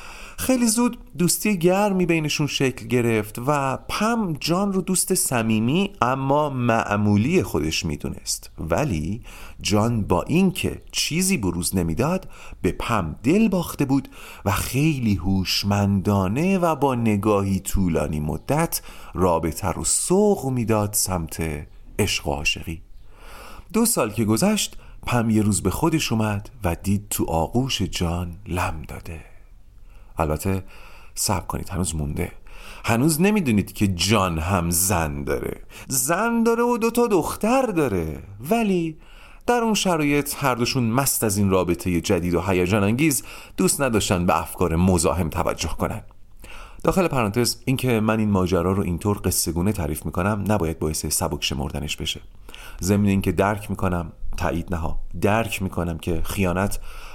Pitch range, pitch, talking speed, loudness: 90-140 Hz, 105 Hz, 135 wpm, -22 LUFS